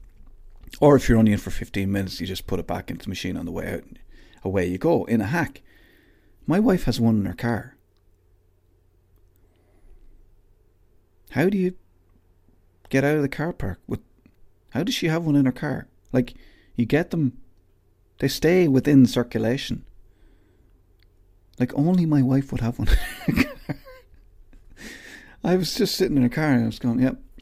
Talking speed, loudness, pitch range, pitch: 180 wpm, -23 LUFS, 90-135 Hz, 110 Hz